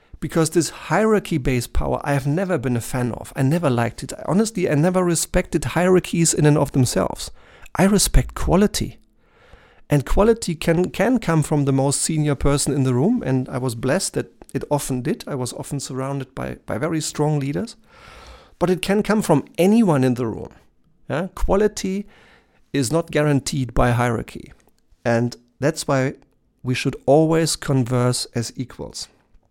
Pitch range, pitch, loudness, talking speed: 130-175 Hz, 145 Hz, -20 LUFS, 170 wpm